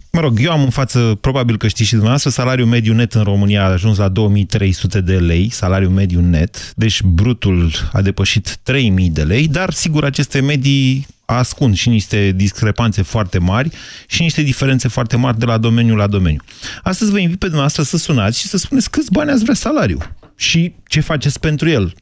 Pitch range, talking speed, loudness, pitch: 100-140 Hz, 195 wpm, -14 LUFS, 115 Hz